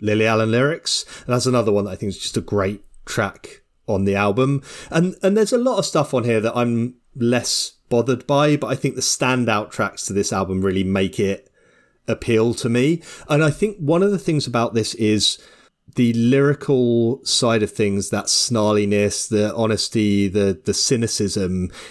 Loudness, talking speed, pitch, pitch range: -19 LUFS, 190 wpm, 115 Hz, 105-135 Hz